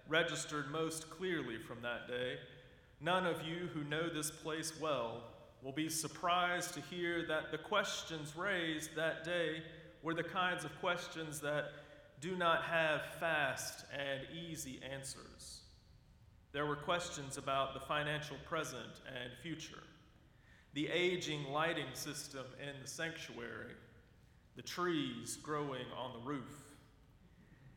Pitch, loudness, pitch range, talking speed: 155 Hz, -40 LUFS, 140-165 Hz, 130 wpm